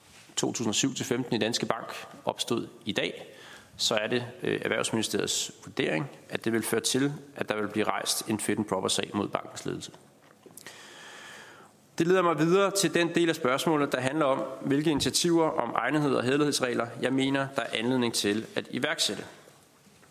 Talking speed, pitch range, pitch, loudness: 165 wpm, 115-155 Hz, 130 Hz, -28 LUFS